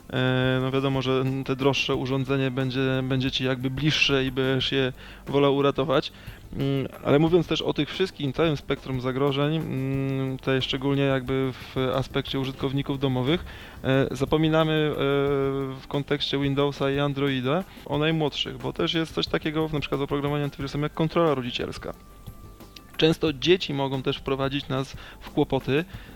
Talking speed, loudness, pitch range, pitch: 140 wpm, -25 LUFS, 130-145 Hz, 135 Hz